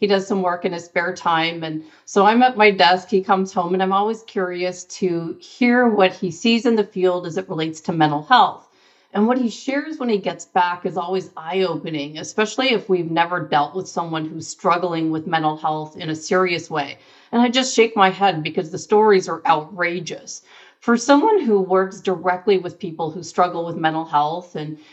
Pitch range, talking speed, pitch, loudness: 165-200 Hz, 205 wpm, 180 Hz, -19 LUFS